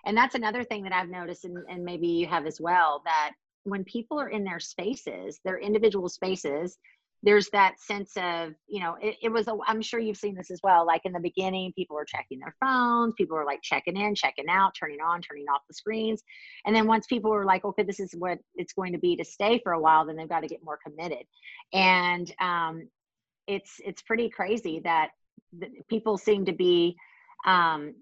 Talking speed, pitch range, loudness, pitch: 220 wpm, 170-215 Hz, -27 LUFS, 185 Hz